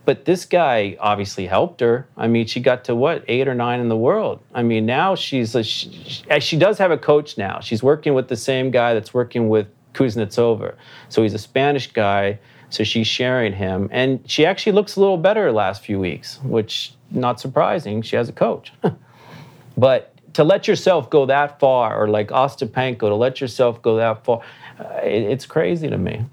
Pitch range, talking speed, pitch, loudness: 110-135 Hz, 205 wpm, 120 Hz, -19 LUFS